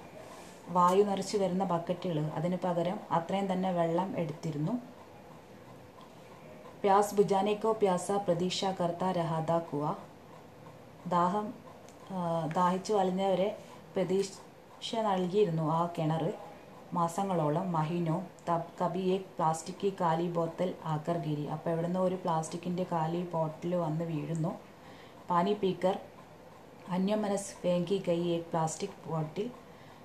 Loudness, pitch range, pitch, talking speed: -32 LUFS, 165-195 Hz, 175 Hz, 90 wpm